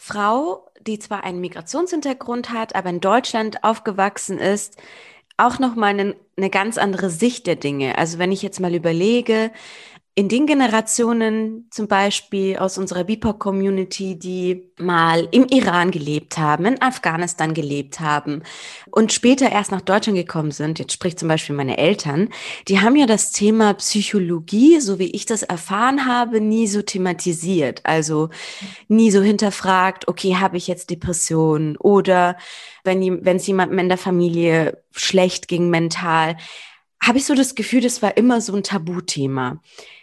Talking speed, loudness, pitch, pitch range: 155 wpm, -19 LUFS, 195 Hz, 175-220 Hz